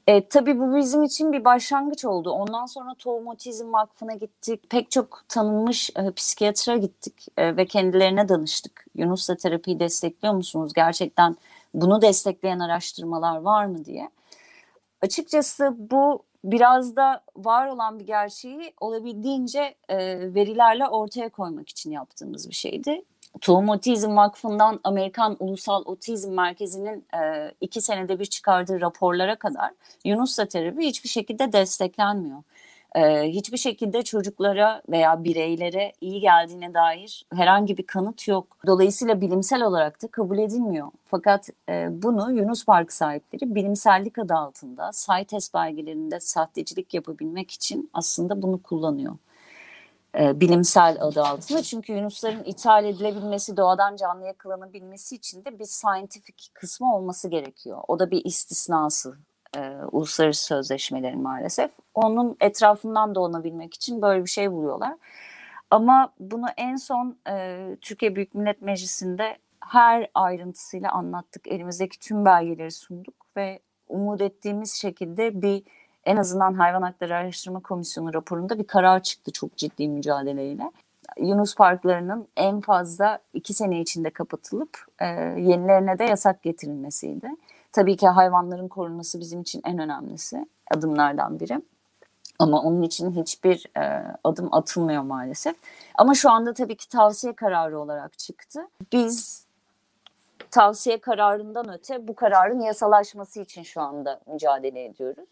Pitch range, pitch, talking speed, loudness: 175-225 Hz, 195 Hz, 125 wpm, -23 LUFS